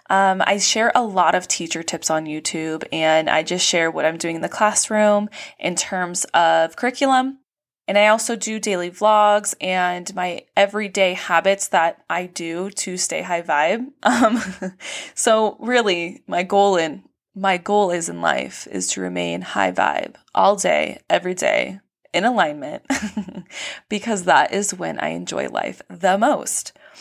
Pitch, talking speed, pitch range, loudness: 190 Hz, 160 wpm, 170-215 Hz, -19 LUFS